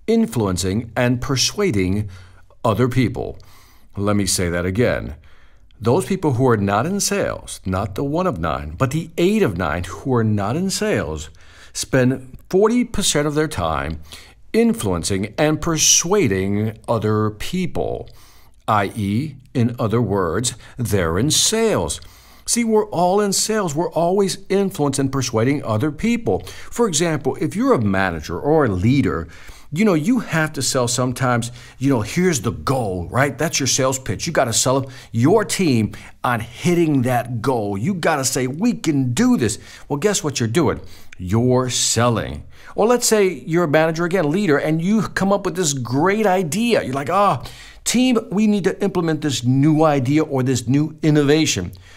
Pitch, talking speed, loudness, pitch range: 135 Hz, 165 wpm, -19 LUFS, 110-175 Hz